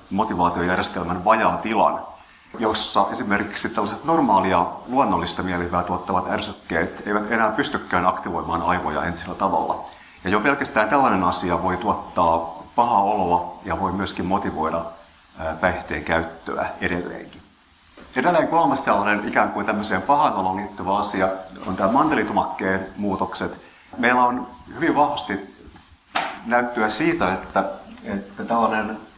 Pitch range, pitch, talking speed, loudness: 85-105 Hz, 95 Hz, 115 wpm, -22 LUFS